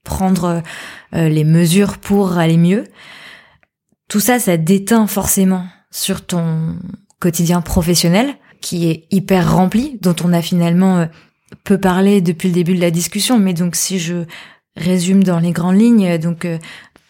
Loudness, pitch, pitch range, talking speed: -15 LUFS, 180 Hz, 170-195 Hz, 145 wpm